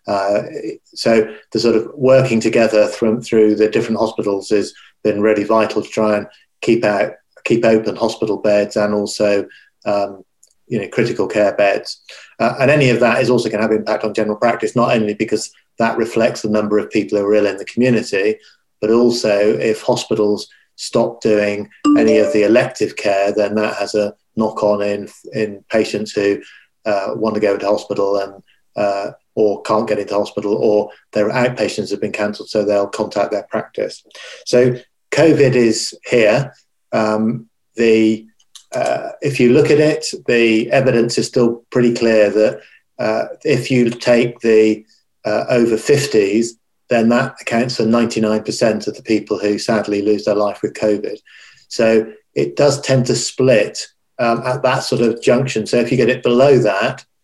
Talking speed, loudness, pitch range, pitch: 175 wpm, -16 LUFS, 105-120 Hz, 110 Hz